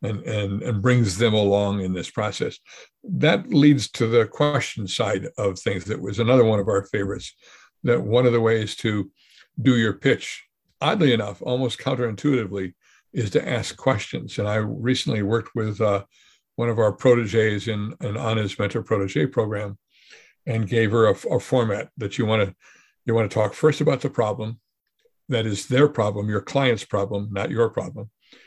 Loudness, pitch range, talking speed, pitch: -22 LUFS, 105-125 Hz, 180 wpm, 110 Hz